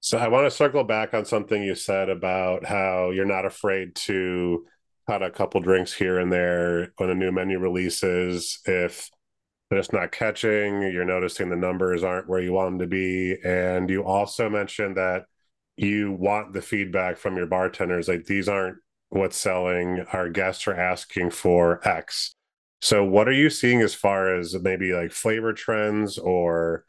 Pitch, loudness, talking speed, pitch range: 95 Hz, -24 LUFS, 180 wpm, 90-100 Hz